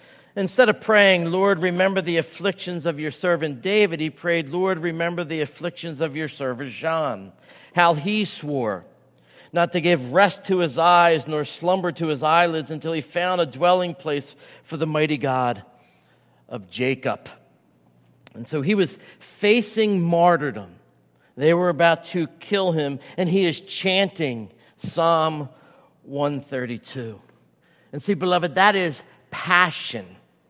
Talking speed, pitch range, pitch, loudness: 140 wpm, 145-180 Hz, 170 Hz, -21 LUFS